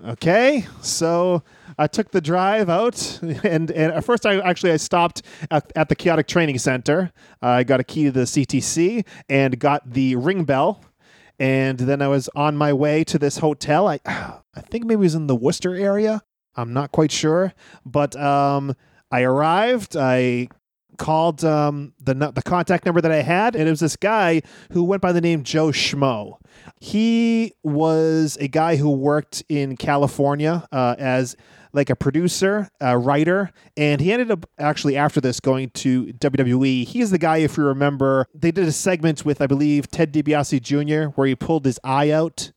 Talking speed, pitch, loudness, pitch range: 185 wpm, 150 Hz, -20 LUFS, 140-175 Hz